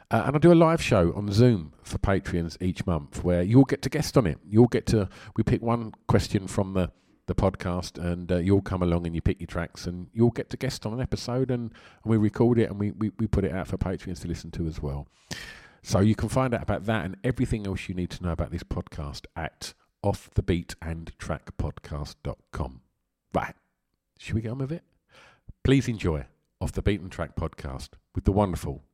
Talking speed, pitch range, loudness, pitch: 225 wpm, 85-115 Hz, -27 LUFS, 95 Hz